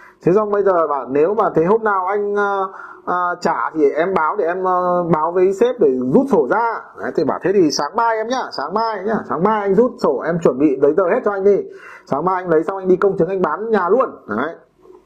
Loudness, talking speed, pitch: -17 LUFS, 265 wpm, 210 Hz